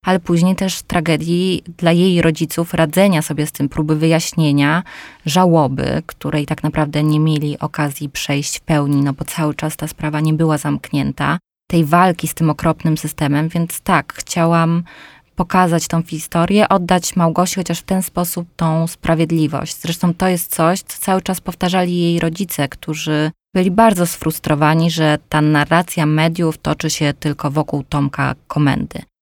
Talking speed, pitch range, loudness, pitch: 155 wpm, 150-175 Hz, -17 LUFS, 160 Hz